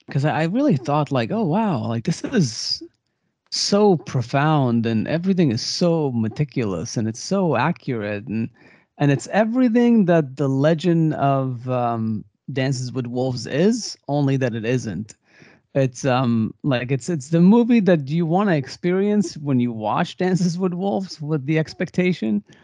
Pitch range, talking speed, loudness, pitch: 125-180 Hz, 155 wpm, -21 LUFS, 145 Hz